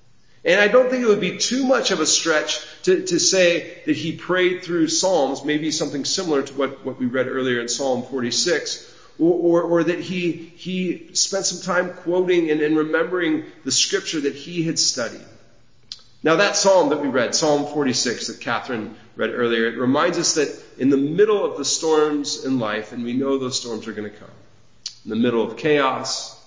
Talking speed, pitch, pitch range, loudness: 200 wpm, 155 Hz, 130-180 Hz, -20 LUFS